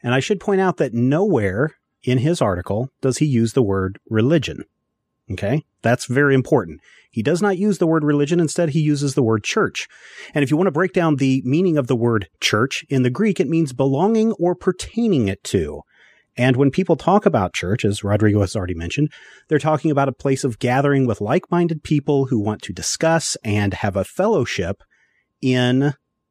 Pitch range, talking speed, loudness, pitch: 115-165 Hz, 195 wpm, -19 LUFS, 140 Hz